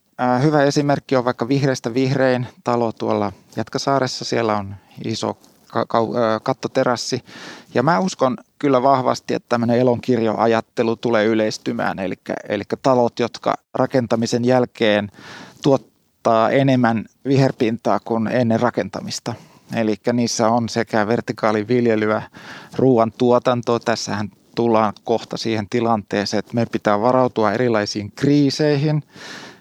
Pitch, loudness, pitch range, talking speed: 115 Hz, -19 LUFS, 110-125 Hz, 105 wpm